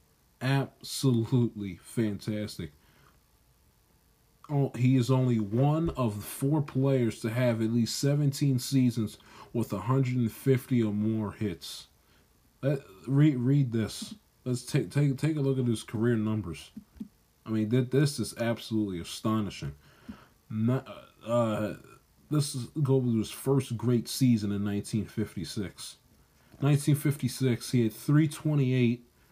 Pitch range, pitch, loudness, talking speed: 110-135 Hz, 120 Hz, -29 LUFS, 115 wpm